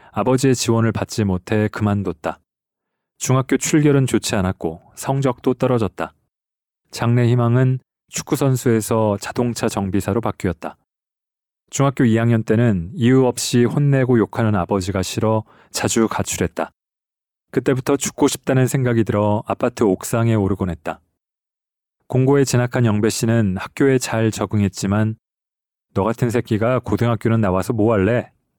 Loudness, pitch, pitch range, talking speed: -19 LUFS, 115 Hz, 105-130 Hz, 305 characters per minute